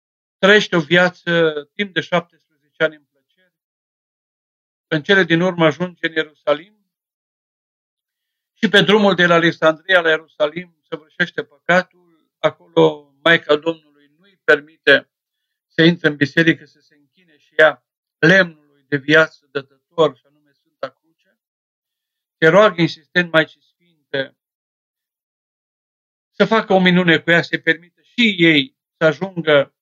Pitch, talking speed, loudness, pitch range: 160 Hz, 135 wpm, -16 LUFS, 150-180 Hz